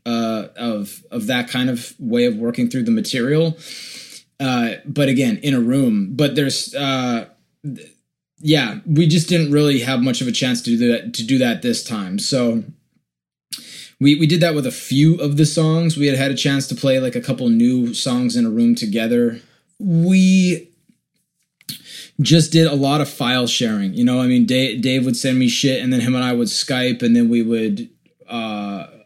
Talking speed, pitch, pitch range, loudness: 200 wpm, 135 Hz, 120-165 Hz, -17 LUFS